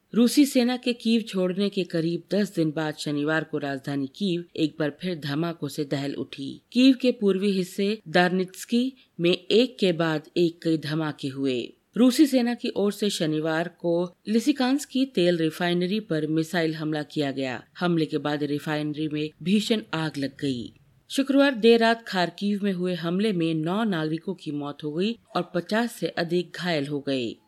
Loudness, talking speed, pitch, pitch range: -25 LUFS, 175 wpm, 175 Hz, 155-210 Hz